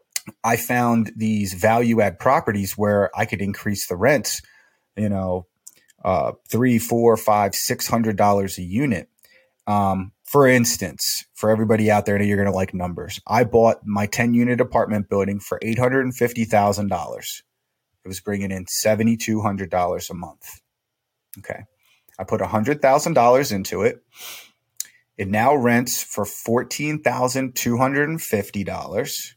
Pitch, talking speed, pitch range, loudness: 110 Hz, 160 wpm, 100-120 Hz, -20 LUFS